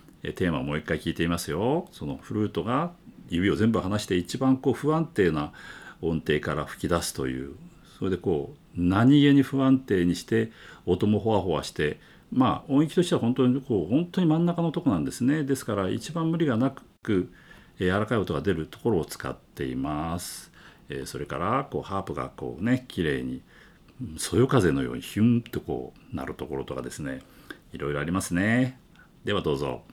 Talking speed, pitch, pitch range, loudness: 360 characters per minute, 110 Hz, 85-135 Hz, -27 LUFS